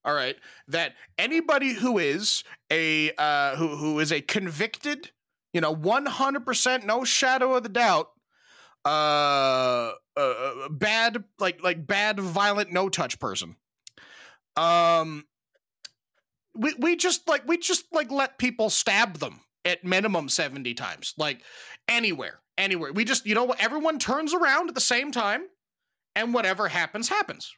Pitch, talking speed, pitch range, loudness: 215 Hz, 150 wpm, 170-265 Hz, -25 LUFS